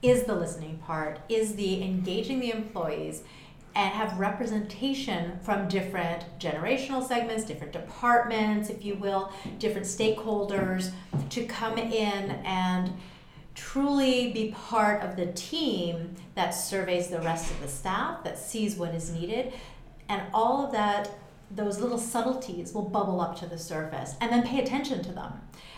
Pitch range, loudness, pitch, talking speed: 175-225 Hz, -30 LUFS, 200 Hz, 150 wpm